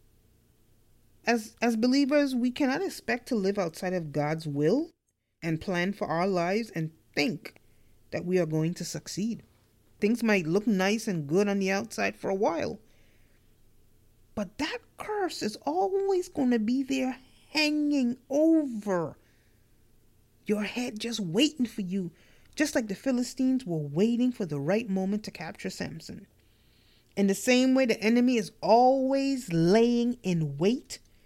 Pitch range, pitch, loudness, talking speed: 155-250 Hz, 200 Hz, -28 LUFS, 150 wpm